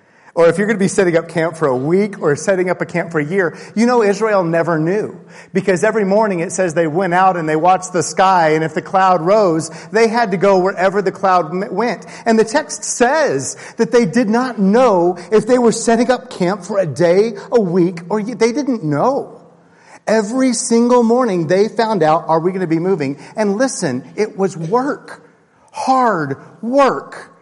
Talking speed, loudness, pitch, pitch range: 205 wpm, -15 LUFS, 195 Hz, 170-225 Hz